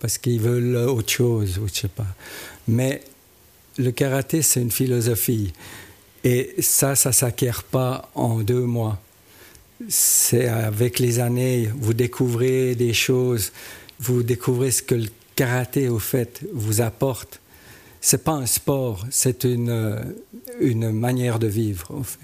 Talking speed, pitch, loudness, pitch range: 150 wpm, 120 Hz, -21 LUFS, 115-130 Hz